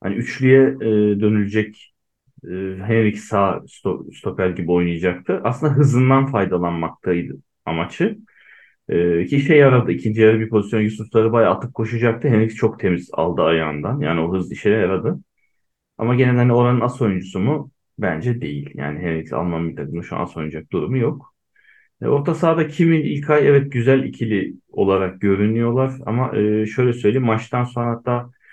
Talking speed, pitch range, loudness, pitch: 145 wpm, 90-125 Hz, -19 LUFS, 110 Hz